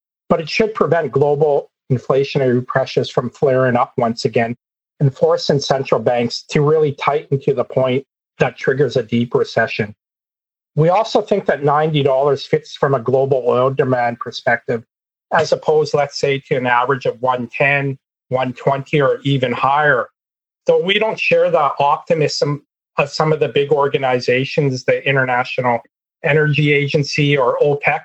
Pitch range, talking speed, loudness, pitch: 130-155 Hz, 150 wpm, -17 LUFS, 140 Hz